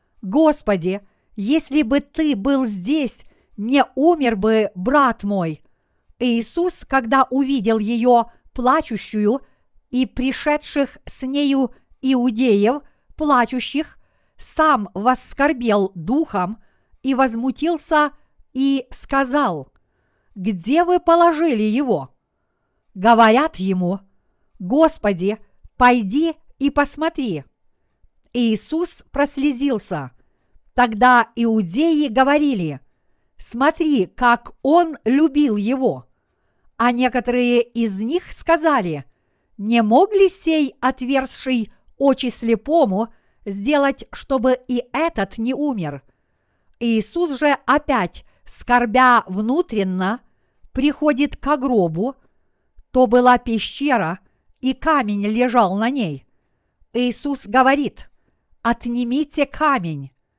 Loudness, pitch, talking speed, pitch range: -19 LUFS, 250 Hz, 85 wpm, 220-285 Hz